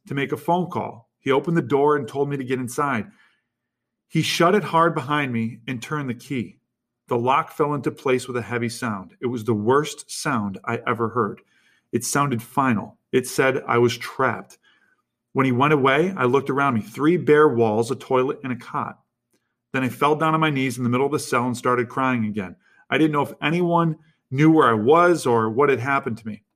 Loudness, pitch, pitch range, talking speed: -22 LUFS, 135 Hz, 120-150 Hz, 220 wpm